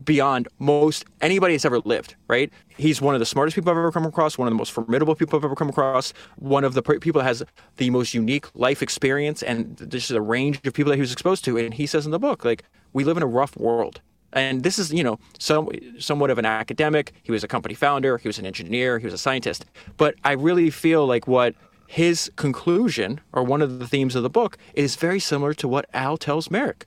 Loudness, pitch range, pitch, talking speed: -22 LUFS, 125-155 Hz, 140 Hz, 245 wpm